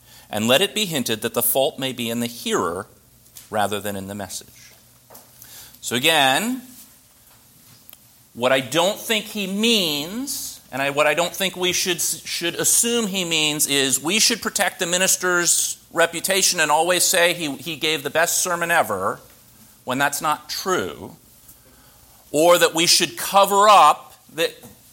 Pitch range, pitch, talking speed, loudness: 125-190 Hz, 165 Hz, 160 wpm, -19 LUFS